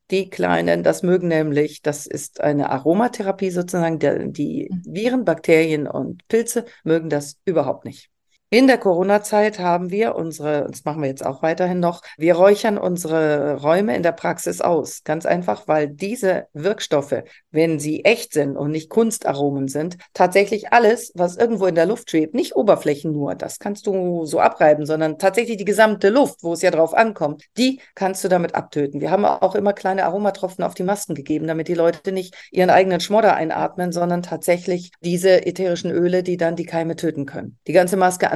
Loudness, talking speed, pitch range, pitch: -19 LUFS, 185 wpm, 155-195 Hz, 175 Hz